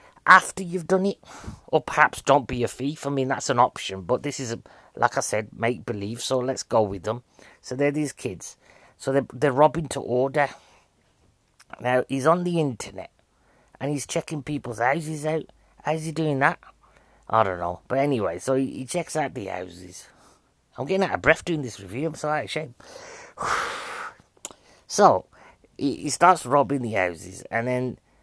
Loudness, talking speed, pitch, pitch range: -24 LUFS, 185 wpm, 135 Hz, 115-155 Hz